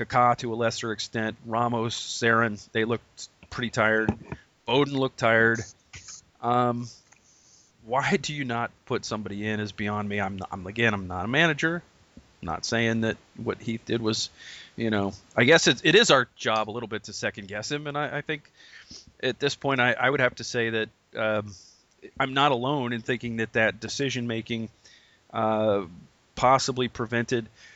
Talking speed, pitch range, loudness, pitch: 180 wpm, 110-125 Hz, -26 LUFS, 115 Hz